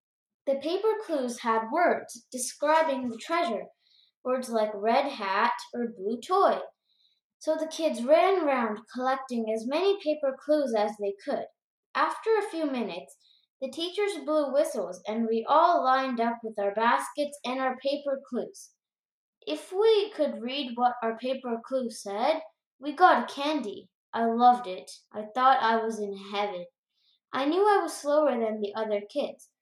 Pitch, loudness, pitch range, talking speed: 260 Hz, -28 LUFS, 225-305 Hz, 160 wpm